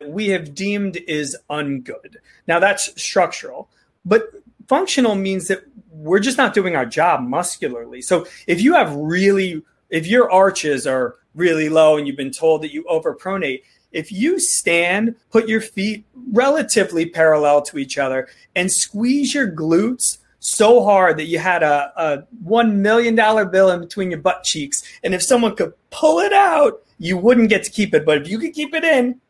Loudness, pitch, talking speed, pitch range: -17 LUFS, 195 Hz, 180 wpm, 160-235 Hz